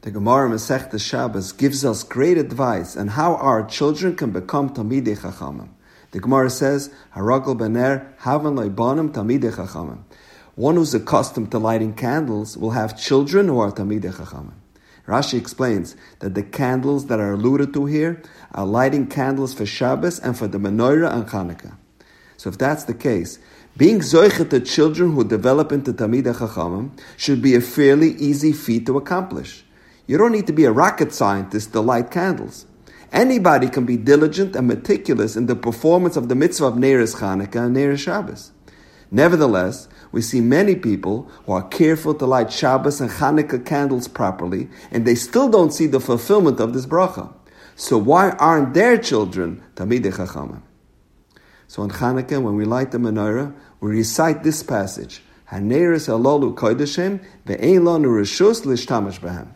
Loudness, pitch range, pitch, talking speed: -18 LUFS, 110-145 Hz, 130 Hz, 150 wpm